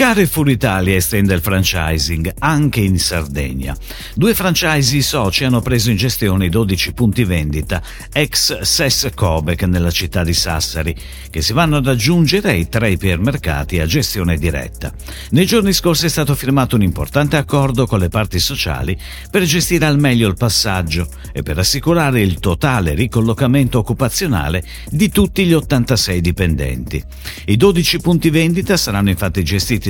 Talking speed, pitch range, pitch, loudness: 150 wpm, 85-140 Hz, 105 Hz, -15 LUFS